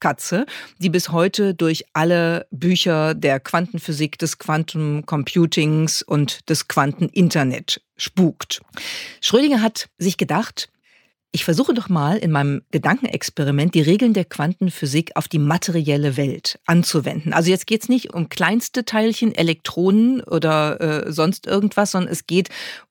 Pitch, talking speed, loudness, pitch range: 170 Hz, 135 wpm, -19 LUFS, 155-190 Hz